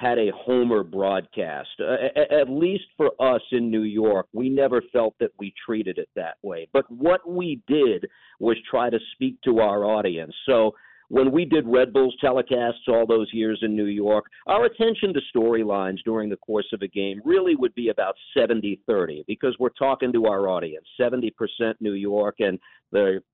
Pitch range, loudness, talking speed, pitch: 105-135 Hz, -23 LUFS, 190 wpm, 115 Hz